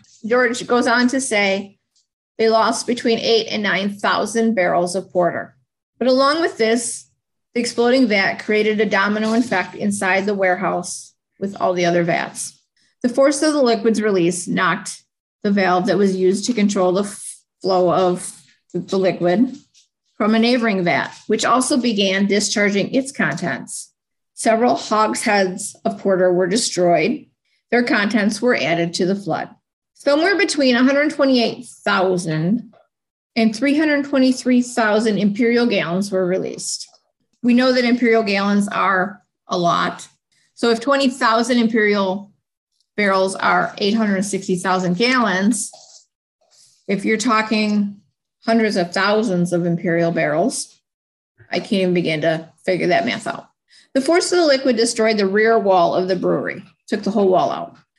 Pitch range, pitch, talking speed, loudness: 185-235 Hz, 210 Hz, 140 wpm, -18 LUFS